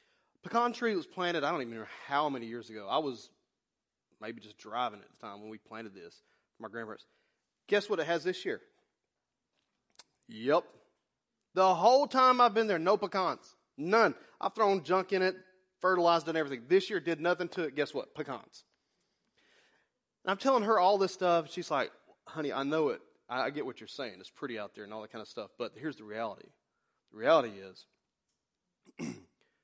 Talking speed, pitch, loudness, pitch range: 195 wpm, 180 Hz, -31 LUFS, 145-205 Hz